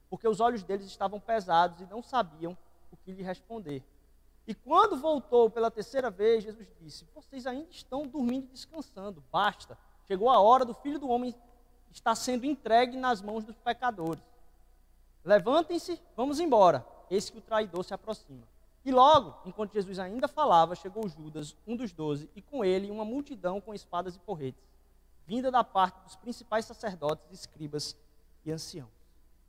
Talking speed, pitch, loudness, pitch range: 165 wpm, 215 Hz, -29 LUFS, 170-245 Hz